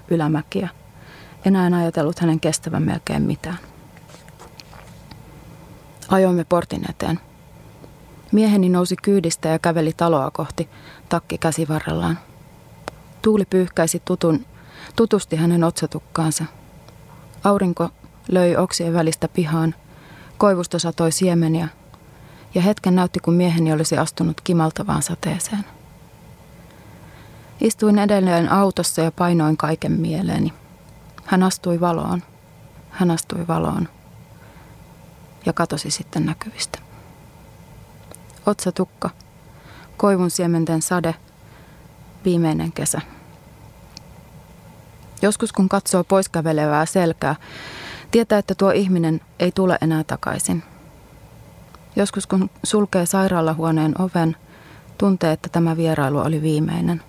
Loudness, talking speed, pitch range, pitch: -20 LUFS, 95 wpm, 160-185 Hz, 170 Hz